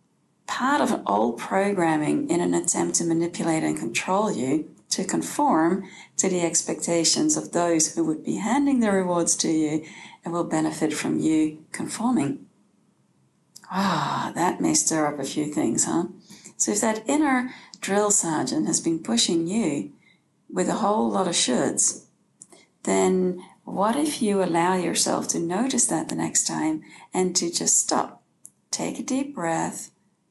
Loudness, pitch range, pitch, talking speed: -23 LUFS, 160-220 Hz, 180 Hz, 160 wpm